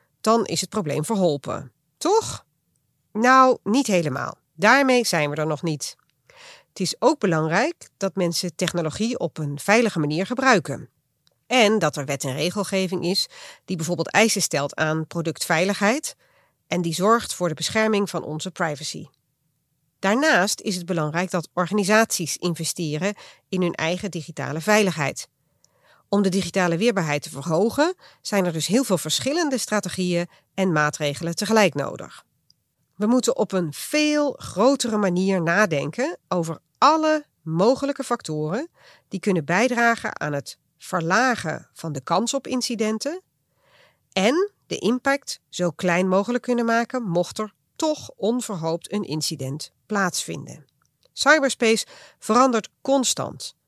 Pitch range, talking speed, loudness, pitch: 160-230 Hz, 135 wpm, -22 LUFS, 190 Hz